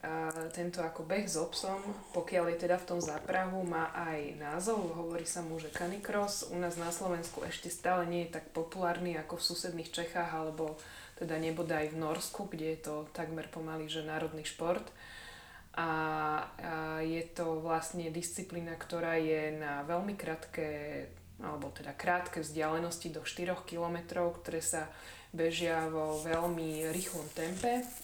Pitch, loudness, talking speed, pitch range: 165 Hz, -37 LUFS, 155 wpm, 160-175 Hz